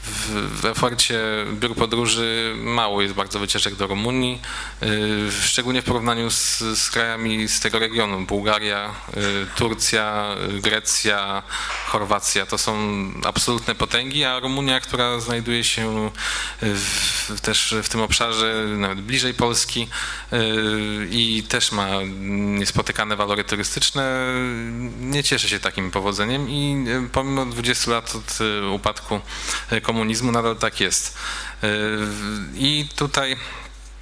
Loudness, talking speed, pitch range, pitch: -21 LUFS, 120 wpm, 105-120 Hz, 110 Hz